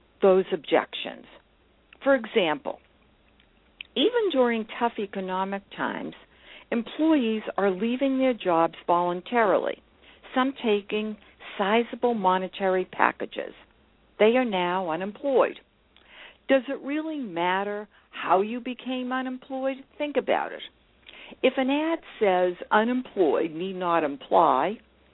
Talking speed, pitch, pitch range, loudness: 105 wpm, 225 Hz, 190-260 Hz, -26 LUFS